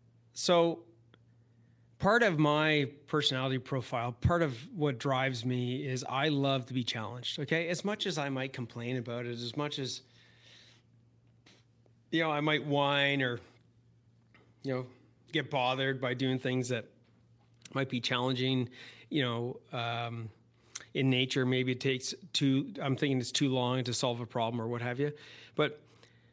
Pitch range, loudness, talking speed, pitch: 120-140 Hz, -32 LUFS, 155 wpm, 130 Hz